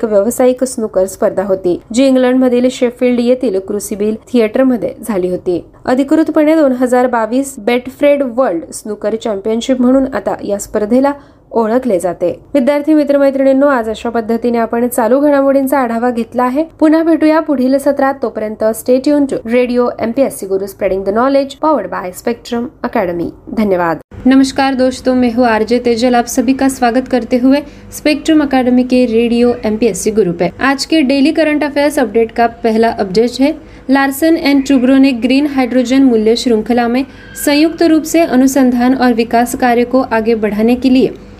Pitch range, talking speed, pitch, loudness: 230-275 Hz, 160 wpm, 250 Hz, -12 LUFS